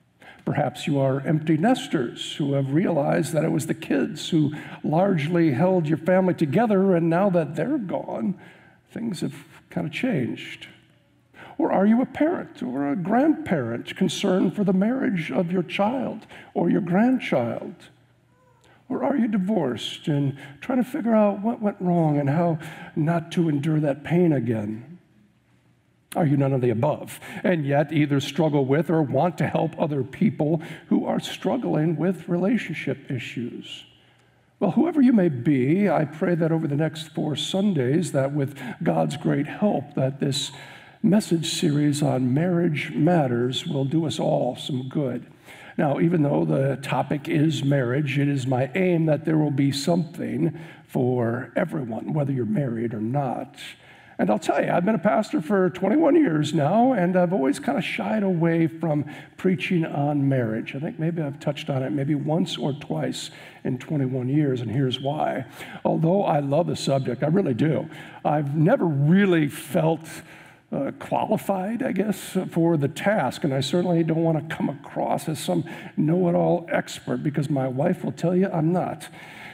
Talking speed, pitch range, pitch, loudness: 170 wpm, 145-185 Hz, 160 Hz, -23 LUFS